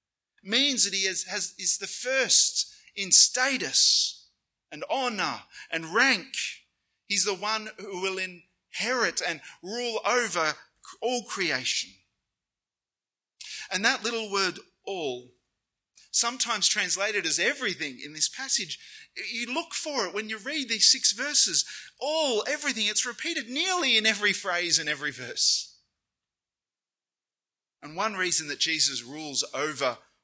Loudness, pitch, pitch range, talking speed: -25 LUFS, 210 Hz, 185-250 Hz, 130 wpm